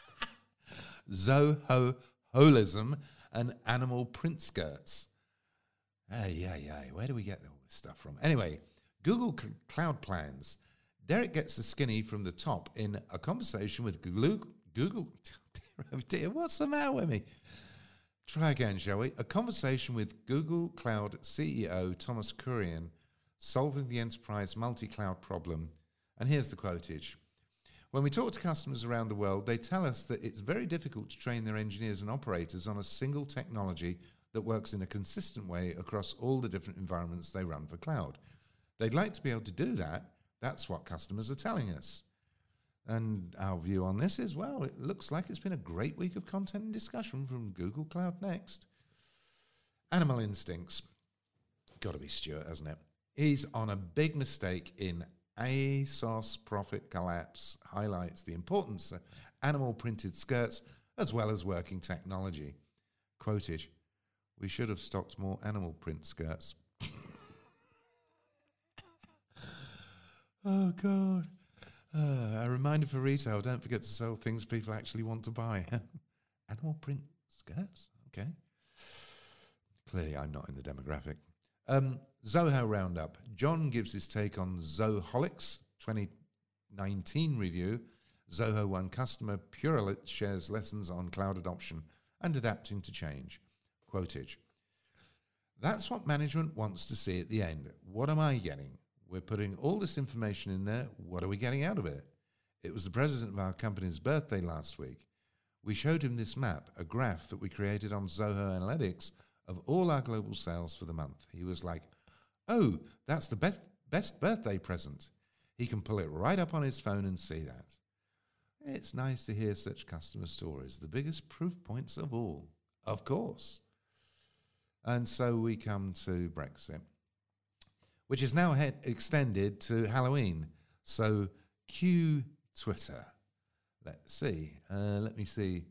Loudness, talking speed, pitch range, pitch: -36 LUFS, 155 wpm, 90-135 Hz, 105 Hz